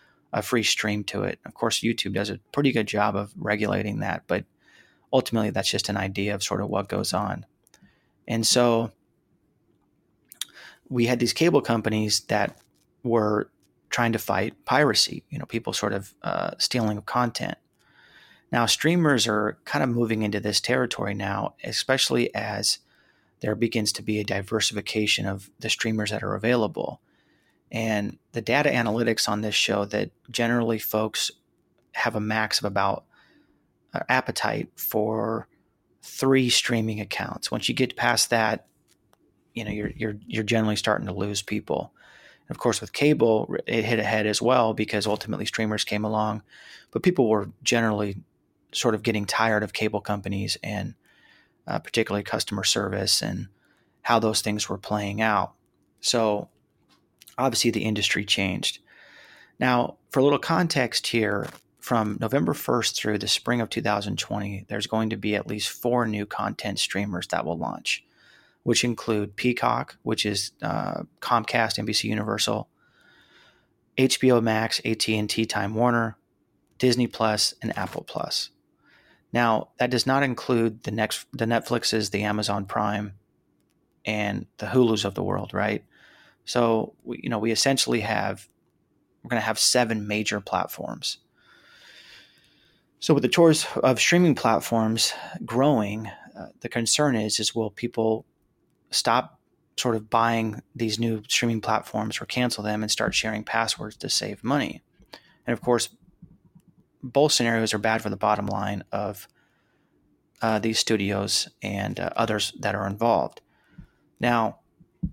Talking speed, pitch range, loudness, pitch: 145 wpm, 105-120 Hz, -25 LUFS, 110 Hz